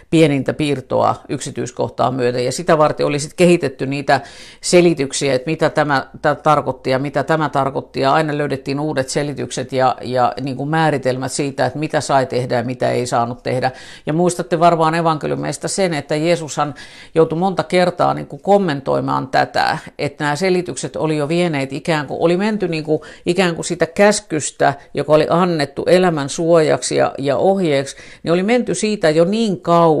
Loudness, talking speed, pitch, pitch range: -17 LUFS, 170 wpm, 155 Hz, 135-170 Hz